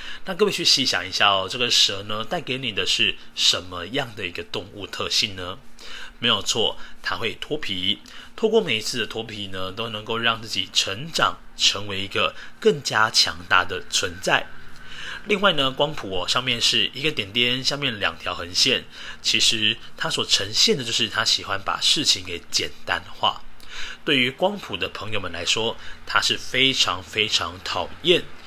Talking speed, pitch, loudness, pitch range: 255 characters per minute, 115 Hz, -21 LUFS, 100-135 Hz